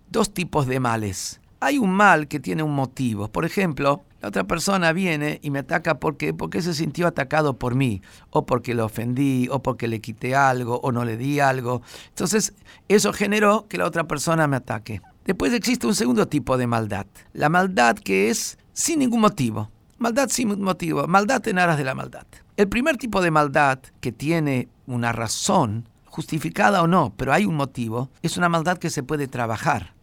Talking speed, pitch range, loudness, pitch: 190 wpm, 120-185 Hz, -22 LUFS, 145 Hz